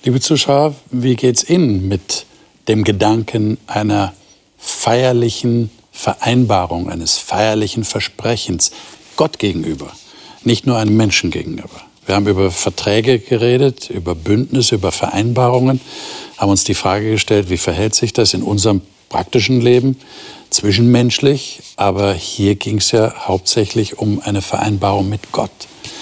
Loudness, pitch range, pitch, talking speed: -15 LUFS, 100-120 Hz, 110 Hz, 130 wpm